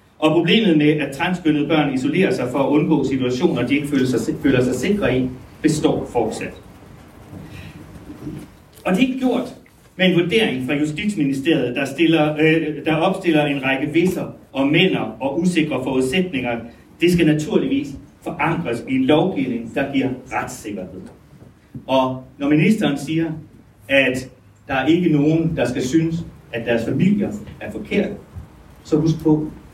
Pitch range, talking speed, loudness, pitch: 130-165 Hz, 150 wpm, -19 LUFS, 150 Hz